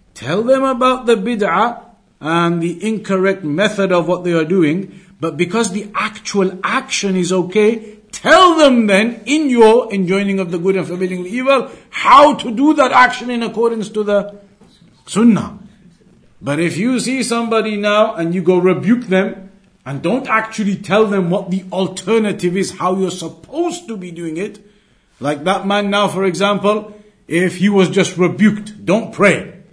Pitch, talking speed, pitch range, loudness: 200 Hz, 170 wpm, 185-220 Hz, -15 LUFS